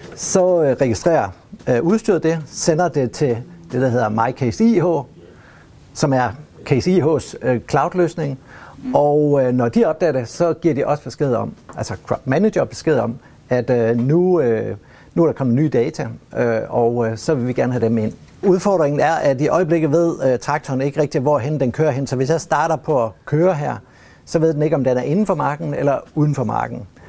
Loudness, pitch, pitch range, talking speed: -18 LUFS, 145 Hz, 125-165 Hz, 185 wpm